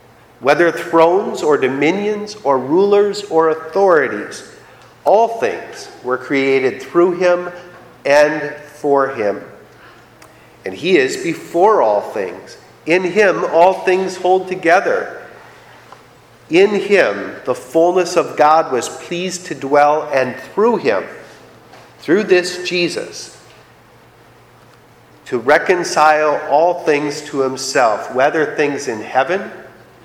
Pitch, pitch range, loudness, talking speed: 170 Hz, 150-185 Hz, -15 LUFS, 110 wpm